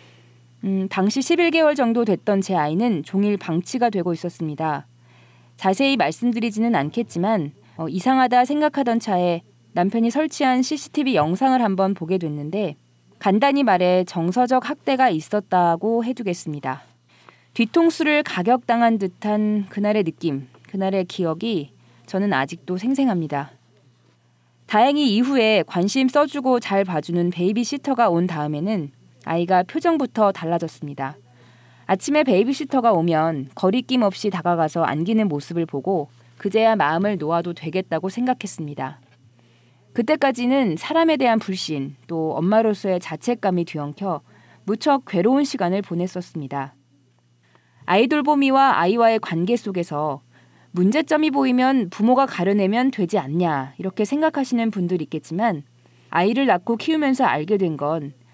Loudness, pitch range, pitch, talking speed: -21 LUFS, 155-240 Hz, 190 Hz, 315 characters per minute